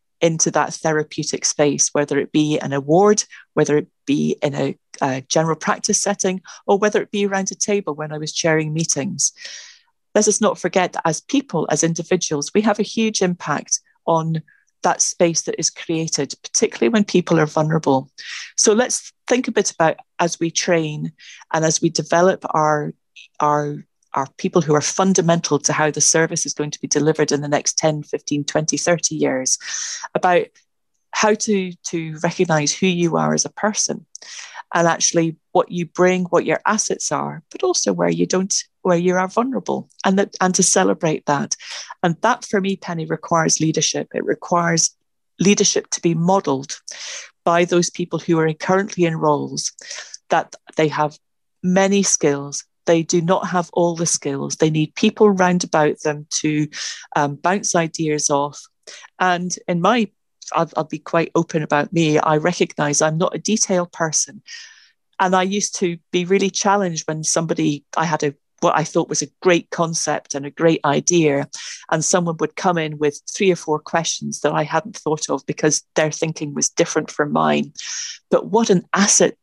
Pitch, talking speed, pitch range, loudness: 165 Hz, 180 wpm, 155-190 Hz, -19 LUFS